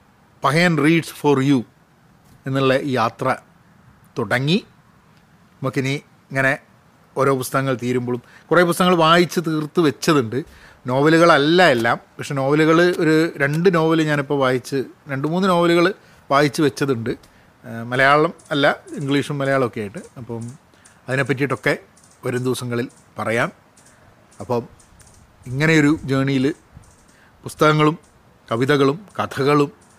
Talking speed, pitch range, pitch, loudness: 95 wpm, 130-160 Hz, 140 Hz, -19 LUFS